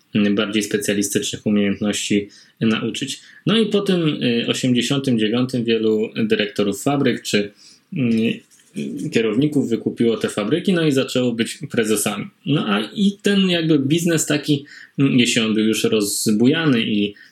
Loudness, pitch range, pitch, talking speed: -19 LUFS, 110-150 Hz, 125 Hz, 120 wpm